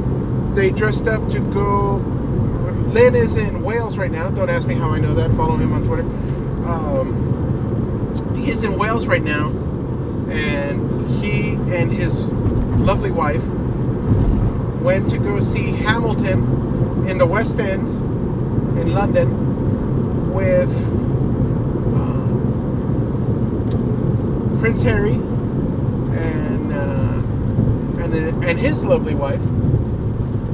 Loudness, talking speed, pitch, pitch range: -19 LUFS, 110 wpm, 120 Hz, 115-125 Hz